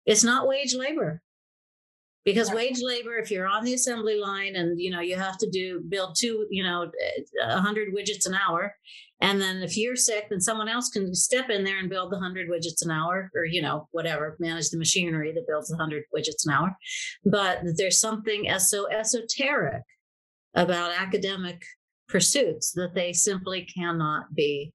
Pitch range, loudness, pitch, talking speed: 175-220 Hz, -26 LUFS, 190 Hz, 180 wpm